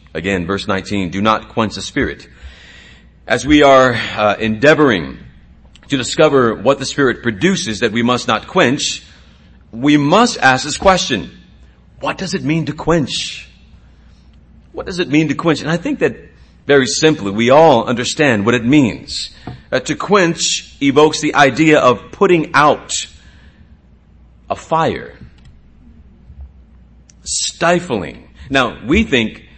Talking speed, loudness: 140 wpm, -14 LUFS